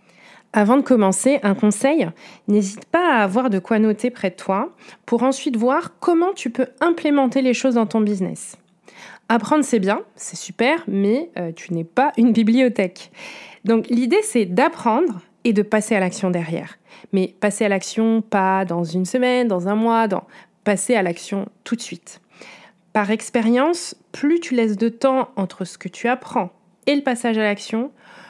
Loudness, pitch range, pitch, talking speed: -20 LUFS, 195-255 Hz, 225 Hz, 180 wpm